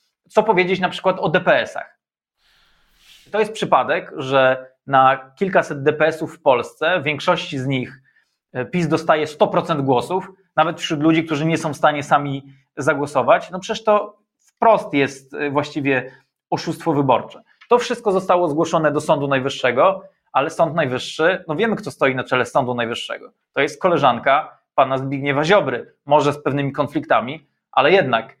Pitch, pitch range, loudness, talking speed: 155 Hz, 140-185 Hz, -19 LUFS, 150 wpm